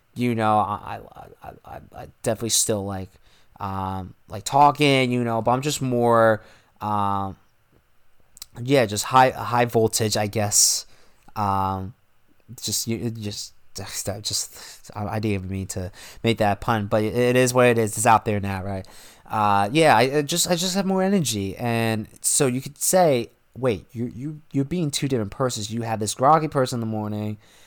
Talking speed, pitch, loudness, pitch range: 175 wpm, 115 Hz, -22 LUFS, 105-130 Hz